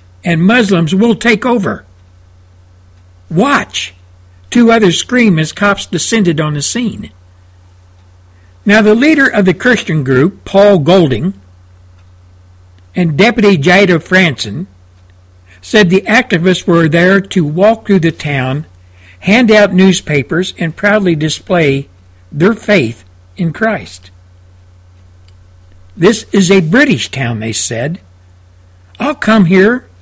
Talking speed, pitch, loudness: 115 wpm, 155 Hz, -10 LUFS